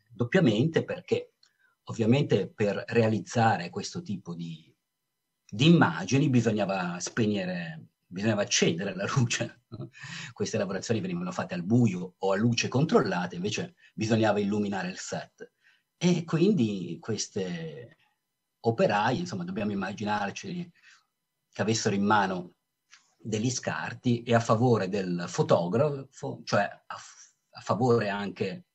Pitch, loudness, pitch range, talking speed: 120 Hz, -28 LUFS, 105-170 Hz, 115 wpm